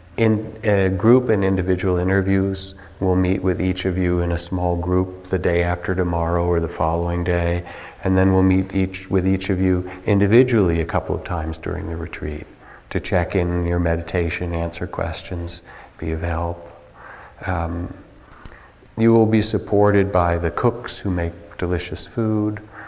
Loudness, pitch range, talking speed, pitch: -21 LUFS, 85-95 Hz, 165 wpm, 90 Hz